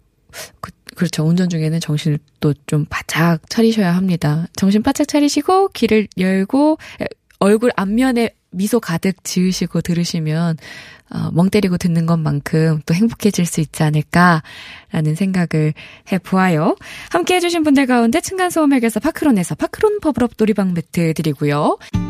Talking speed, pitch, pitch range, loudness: 325 characters per minute, 185 Hz, 160-230 Hz, -17 LUFS